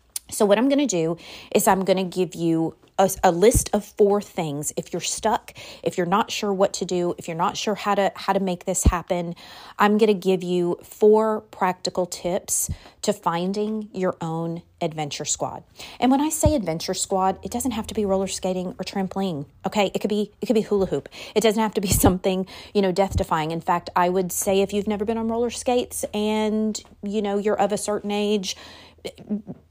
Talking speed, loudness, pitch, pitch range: 215 wpm, -23 LUFS, 195 Hz, 180-210 Hz